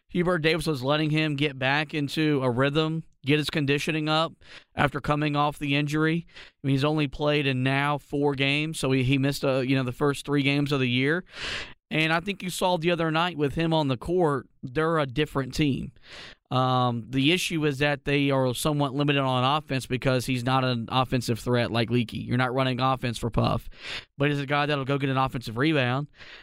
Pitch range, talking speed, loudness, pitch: 130-155 Hz, 215 wpm, -25 LUFS, 145 Hz